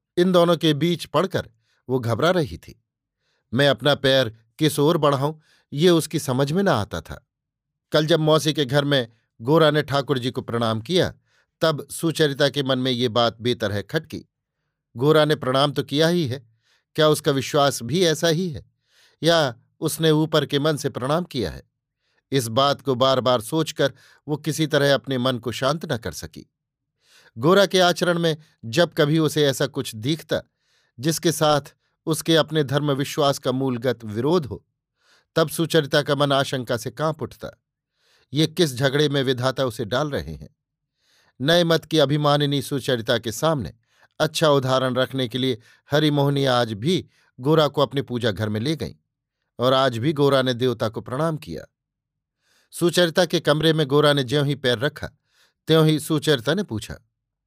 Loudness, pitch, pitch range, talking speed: -21 LUFS, 145 Hz, 130-155 Hz, 175 wpm